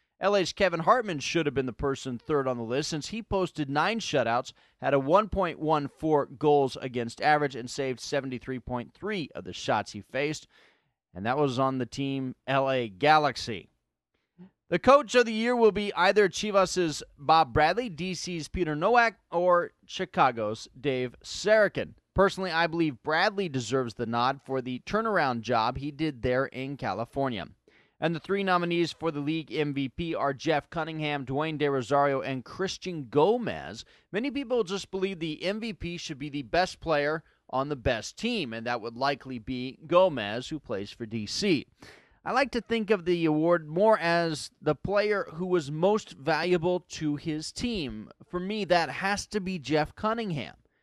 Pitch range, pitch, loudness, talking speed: 135-185 Hz, 155 Hz, -28 LUFS, 165 wpm